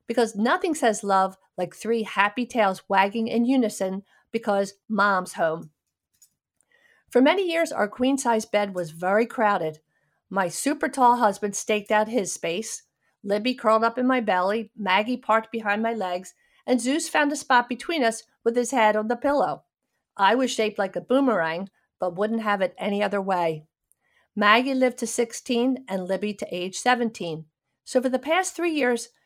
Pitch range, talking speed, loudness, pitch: 195-250 Hz, 170 wpm, -24 LUFS, 220 Hz